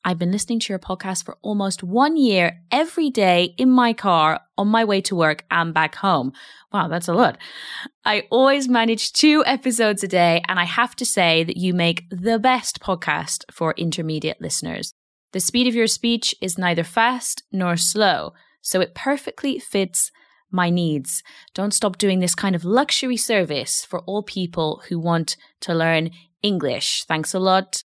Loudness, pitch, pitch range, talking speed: -20 LUFS, 190 Hz, 170-235 Hz, 180 wpm